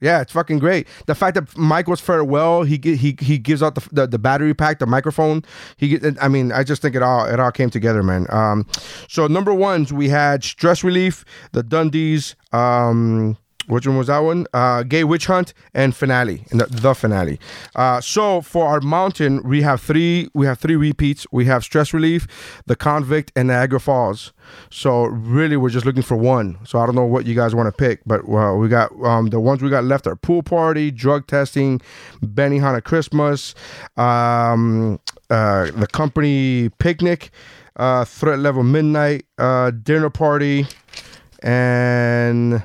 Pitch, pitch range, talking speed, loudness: 135 Hz, 120-155 Hz, 185 wpm, -17 LUFS